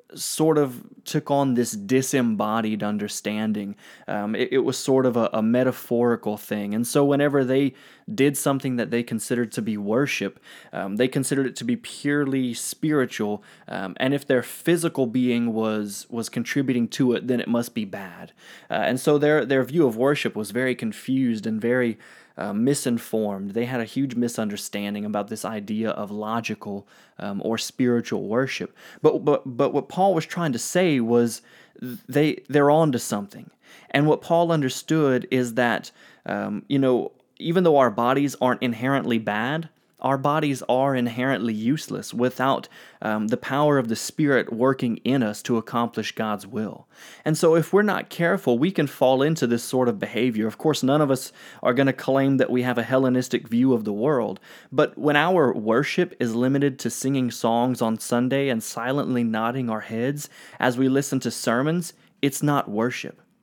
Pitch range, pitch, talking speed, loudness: 115-140 Hz, 125 Hz, 180 wpm, -23 LUFS